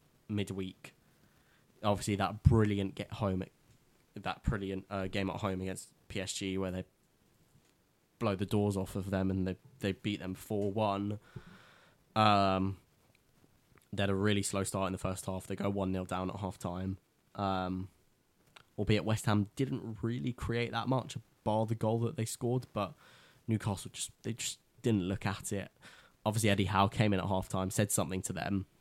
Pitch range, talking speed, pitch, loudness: 95-110 Hz, 175 wpm, 100 Hz, -34 LUFS